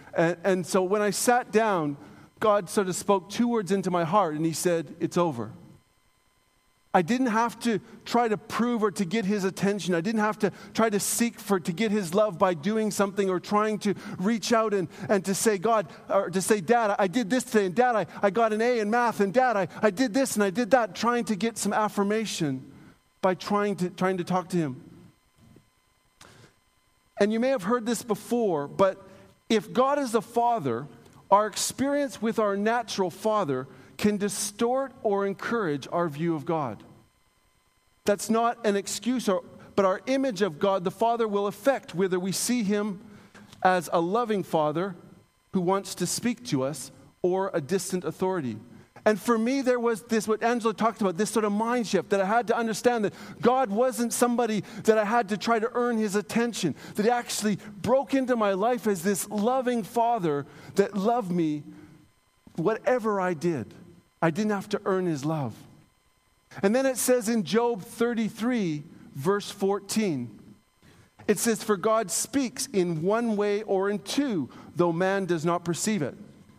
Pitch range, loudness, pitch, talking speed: 185-230 Hz, -26 LUFS, 205 Hz, 185 wpm